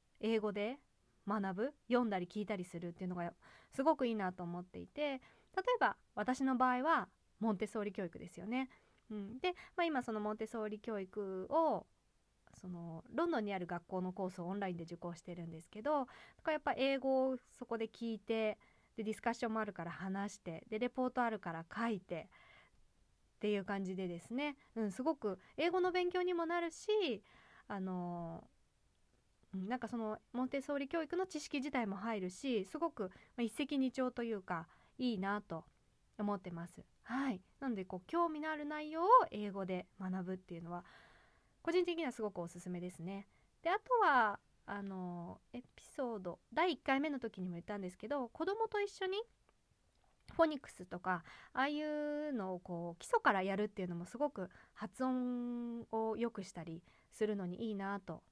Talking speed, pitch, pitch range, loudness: 345 characters per minute, 220 Hz, 185-275 Hz, -40 LUFS